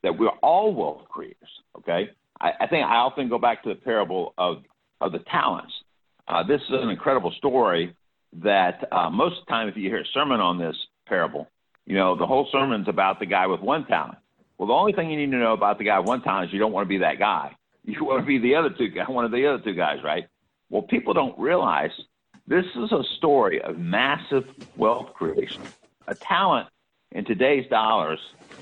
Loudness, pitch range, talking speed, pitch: -23 LUFS, 95-145 Hz, 220 wpm, 130 Hz